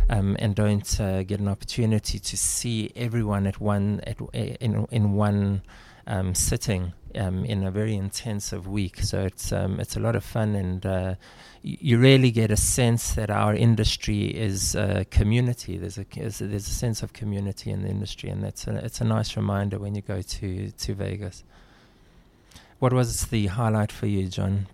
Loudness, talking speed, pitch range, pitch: -25 LUFS, 190 wpm, 100-110 Hz, 105 Hz